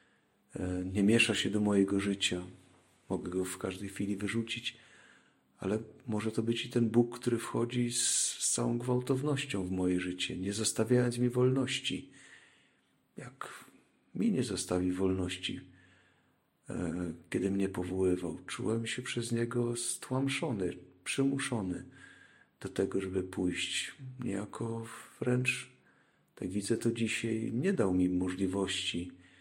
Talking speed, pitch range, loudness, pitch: 120 wpm, 90-120 Hz, -33 LUFS, 105 Hz